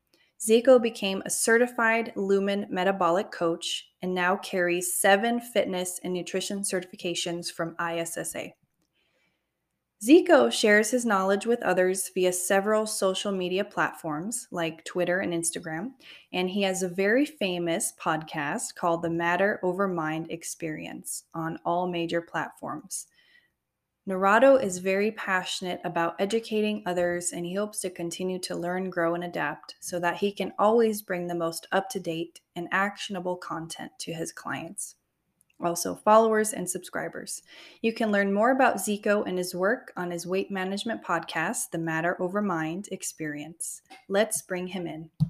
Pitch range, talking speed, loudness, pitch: 170-210 Hz, 145 wpm, -27 LUFS, 185 Hz